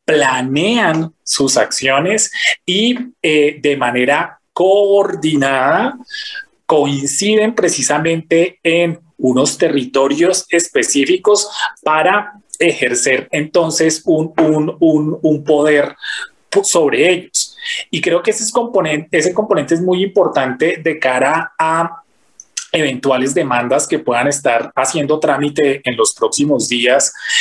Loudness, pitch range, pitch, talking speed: -14 LUFS, 145-205 Hz, 165 Hz, 110 wpm